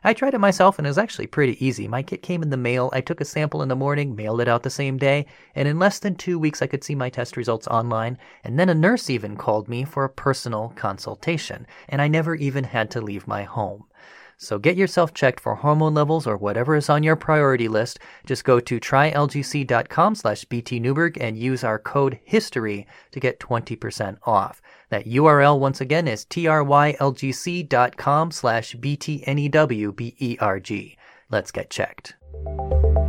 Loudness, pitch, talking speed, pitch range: -22 LUFS, 135 Hz, 180 wpm, 115-150 Hz